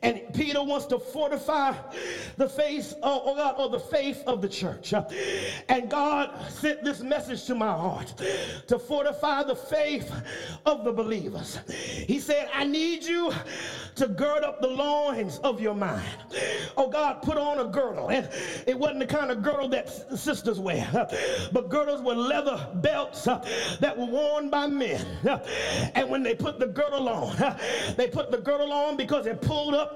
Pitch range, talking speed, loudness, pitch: 250-295 Hz, 170 wpm, -28 LUFS, 280 Hz